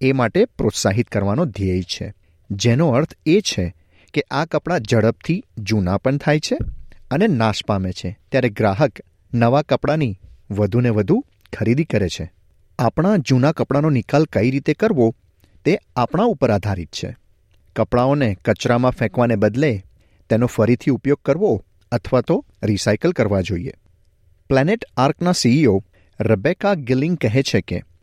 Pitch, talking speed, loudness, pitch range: 115 Hz, 135 wpm, -19 LUFS, 95-135 Hz